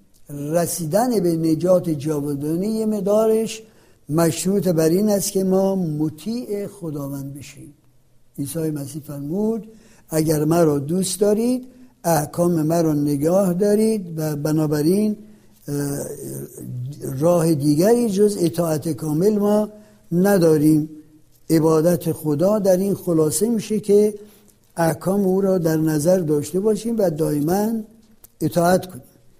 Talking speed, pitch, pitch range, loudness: 105 wpm, 170 Hz, 155-205 Hz, -20 LUFS